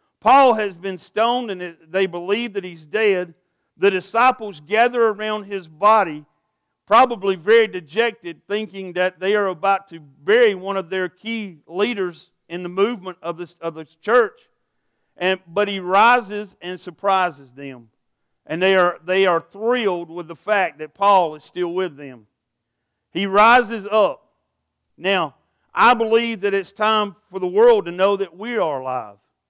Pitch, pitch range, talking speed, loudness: 195 Hz, 175-215 Hz, 160 wpm, -19 LUFS